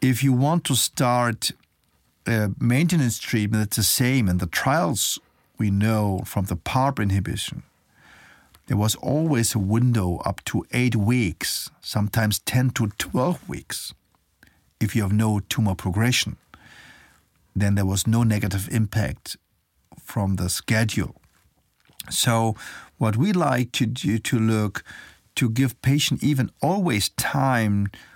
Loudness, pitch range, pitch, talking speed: -23 LUFS, 105-125 Hz, 110 Hz, 135 wpm